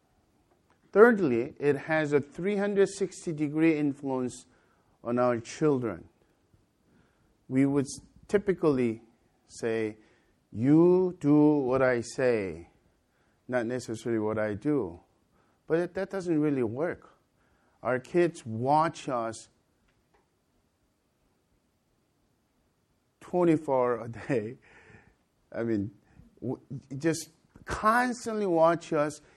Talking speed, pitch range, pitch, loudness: 90 wpm, 115-160 Hz, 140 Hz, -28 LUFS